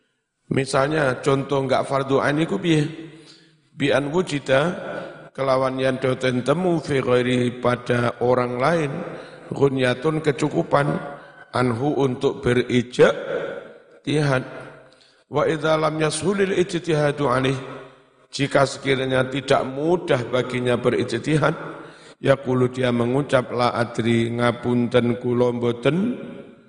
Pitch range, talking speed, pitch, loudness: 125-155 Hz, 95 wpm, 135 Hz, -21 LUFS